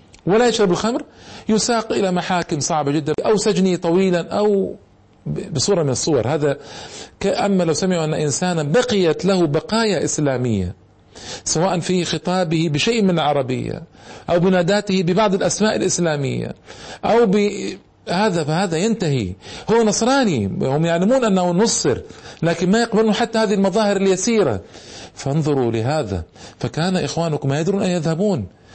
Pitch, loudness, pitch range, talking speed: 180 Hz, -19 LUFS, 155-205 Hz, 125 wpm